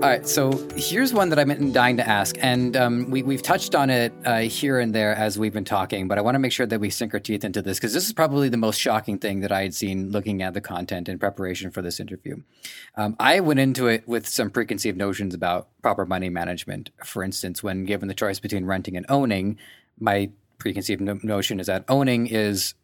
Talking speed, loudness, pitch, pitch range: 235 wpm, -23 LUFS, 105 Hz, 95-125 Hz